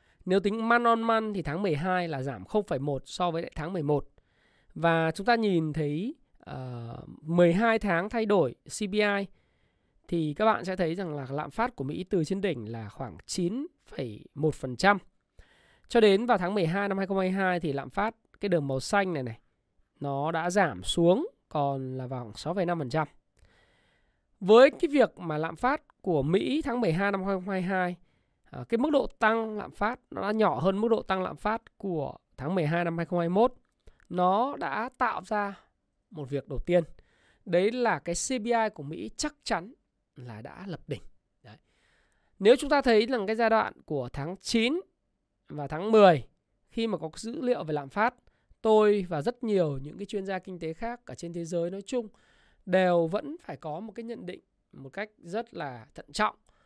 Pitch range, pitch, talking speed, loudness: 160-220 Hz, 185 Hz, 185 wpm, -28 LUFS